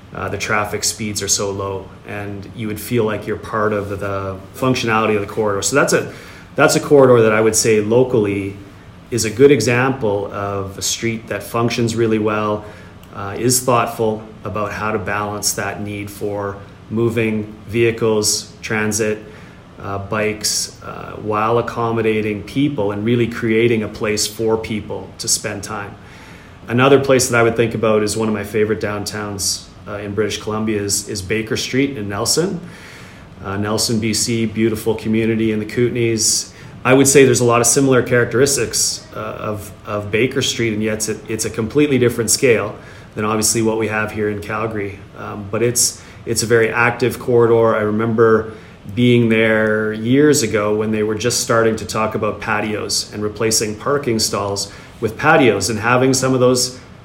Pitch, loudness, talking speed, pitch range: 110 Hz, -17 LUFS, 175 wpm, 105-115 Hz